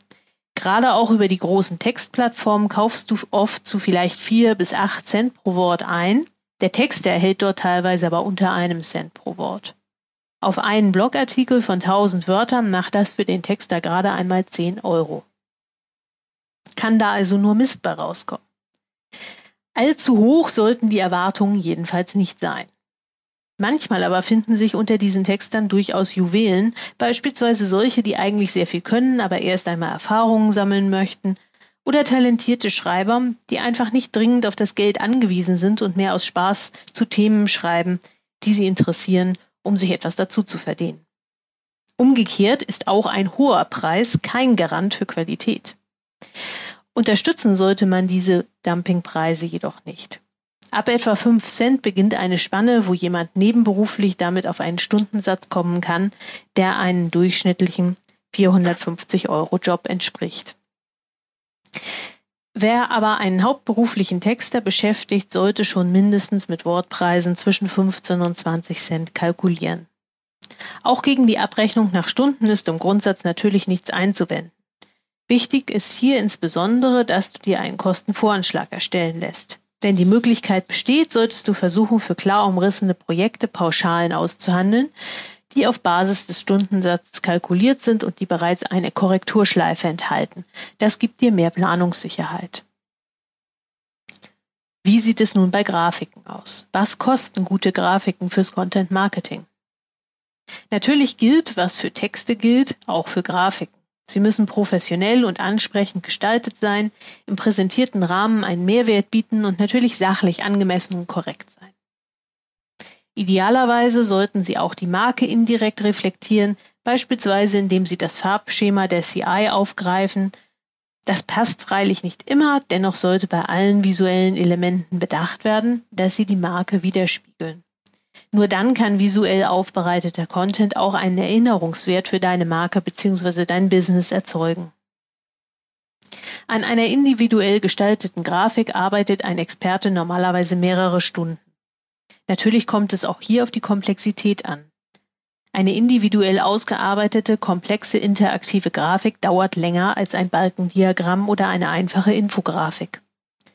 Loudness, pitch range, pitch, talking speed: -19 LUFS, 180-220 Hz, 195 Hz, 135 wpm